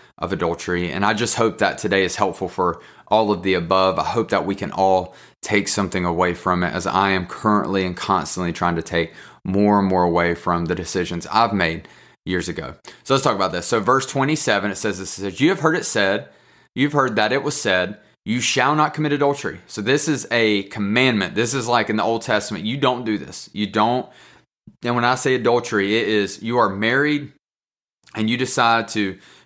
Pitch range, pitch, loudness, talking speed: 95-120 Hz, 105 Hz, -20 LUFS, 220 wpm